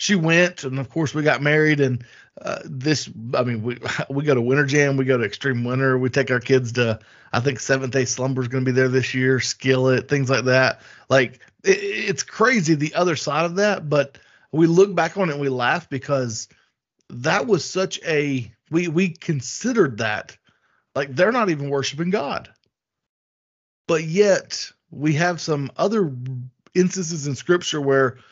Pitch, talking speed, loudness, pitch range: 140 Hz, 185 wpm, -21 LUFS, 130-170 Hz